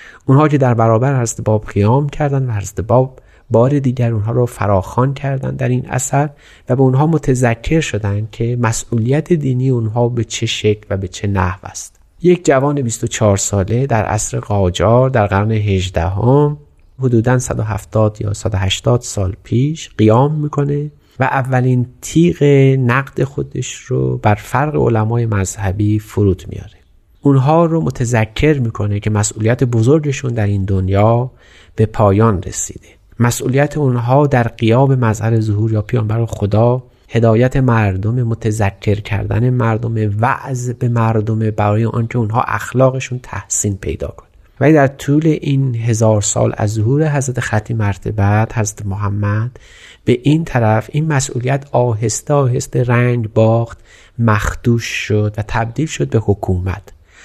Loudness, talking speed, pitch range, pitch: -15 LUFS, 140 wpm, 105-130 Hz, 115 Hz